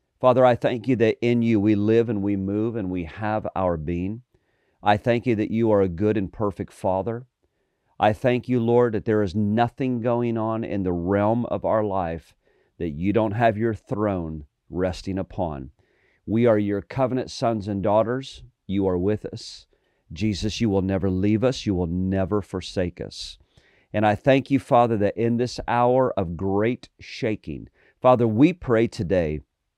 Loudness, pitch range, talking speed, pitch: -23 LUFS, 95-120 Hz, 180 wpm, 105 Hz